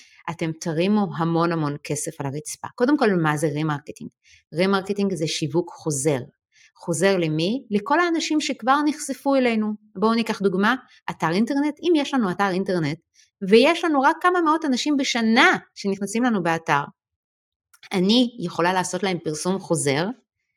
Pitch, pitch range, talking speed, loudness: 195 Hz, 165-250 Hz, 145 wpm, -22 LUFS